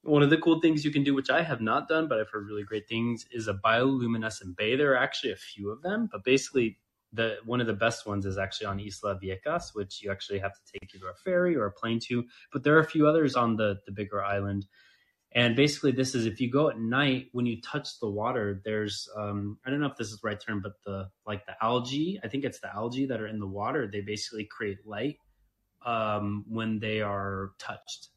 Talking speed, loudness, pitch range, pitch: 245 wpm, -29 LUFS, 100-130 Hz, 110 Hz